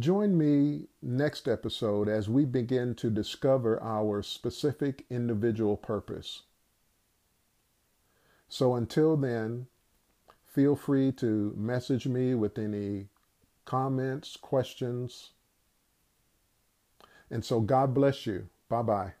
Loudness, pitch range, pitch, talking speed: -30 LUFS, 110-135 Hz, 120 Hz, 100 wpm